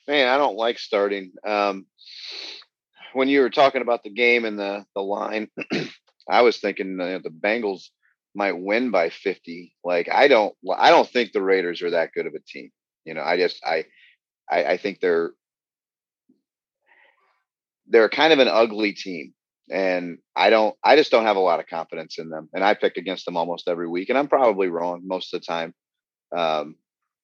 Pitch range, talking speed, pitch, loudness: 90-135 Hz, 190 wpm, 100 Hz, -21 LUFS